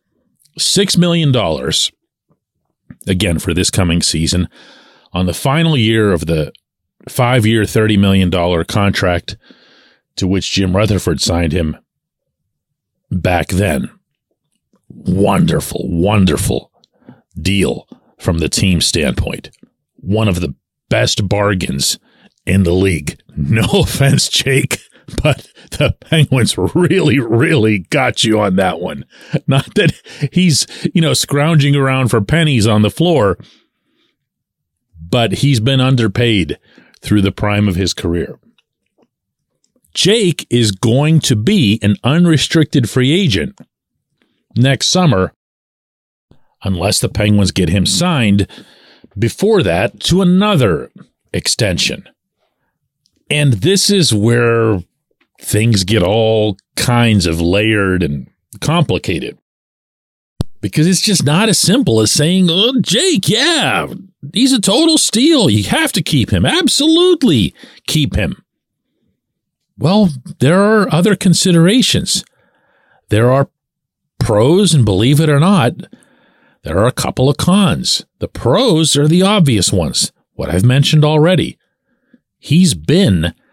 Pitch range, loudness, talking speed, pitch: 100-165 Hz, -13 LUFS, 120 wpm, 125 Hz